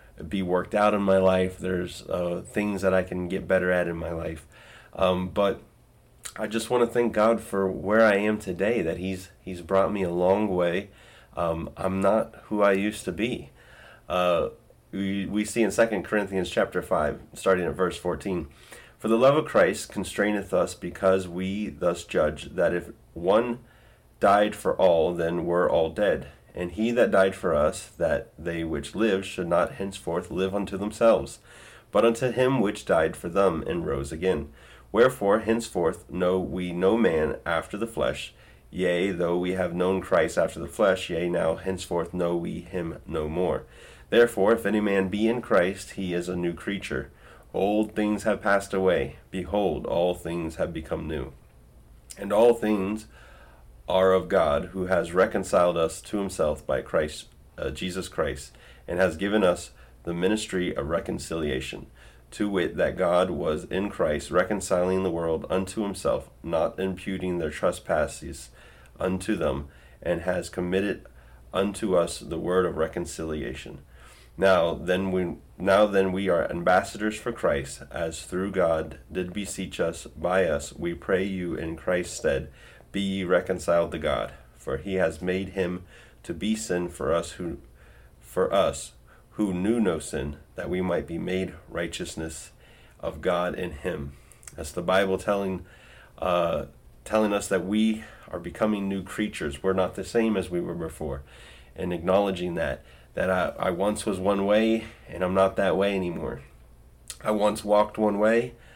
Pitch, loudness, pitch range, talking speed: 95 Hz, -26 LUFS, 85-100 Hz, 170 wpm